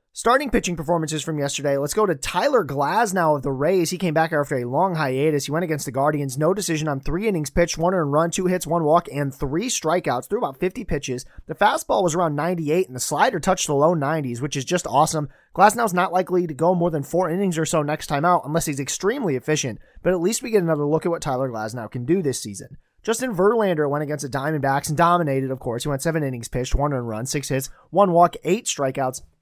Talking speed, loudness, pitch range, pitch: 235 wpm, -22 LUFS, 140-180 Hz, 155 Hz